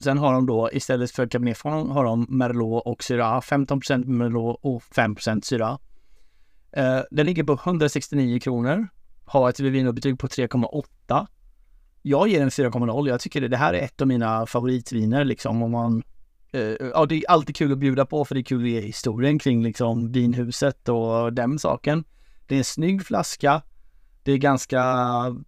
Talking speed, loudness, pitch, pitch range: 175 wpm, -23 LUFS, 130 Hz, 120-140 Hz